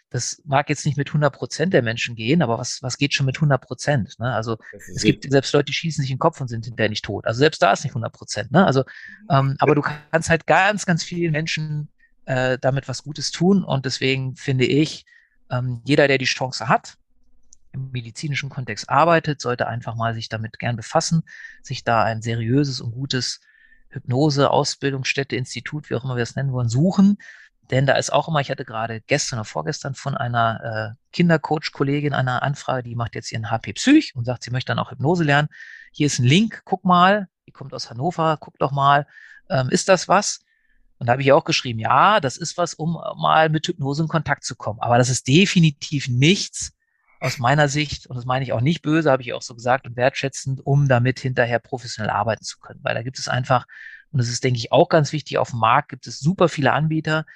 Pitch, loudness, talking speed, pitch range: 140 Hz, -21 LUFS, 220 wpm, 125-160 Hz